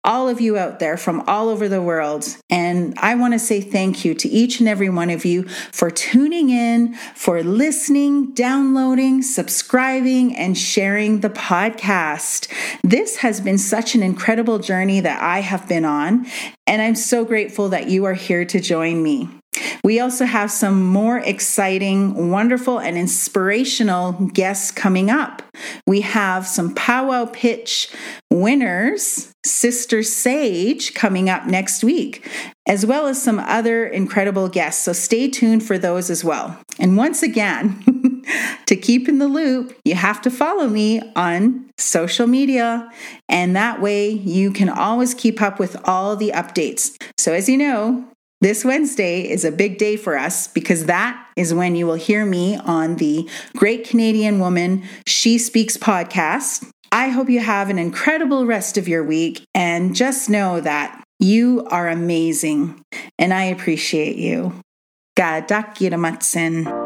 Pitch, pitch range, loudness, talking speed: 210 Hz, 185-245 Hz, -18 LUFS, 155 wpm